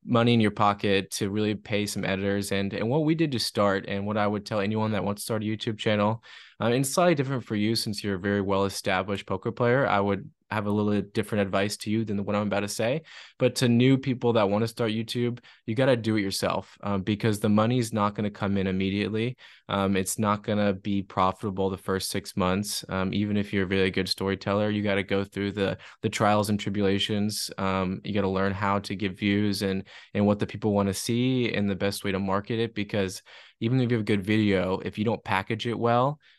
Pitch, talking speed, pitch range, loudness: 105 Hz, 250 wpm, 100-110 Hz, -26 LUFS